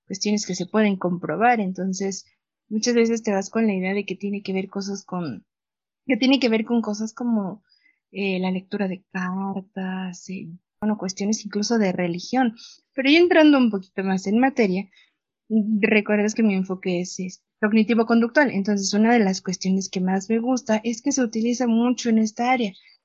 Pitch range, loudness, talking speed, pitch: 190-235 Hz, -22 LUFS, 185 wpm, 210 Hz